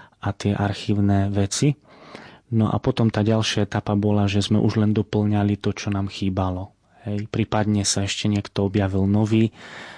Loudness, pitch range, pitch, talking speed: -22 LUFS, 100-110 Hz, 105 Hz, 160 wpm